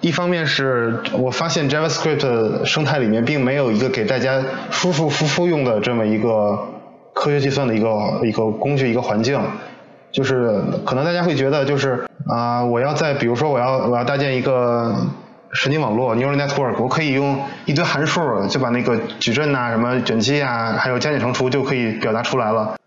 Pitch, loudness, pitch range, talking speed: 130 Hz, -19 LUFS, 115-145 Hz, 350 characters per minute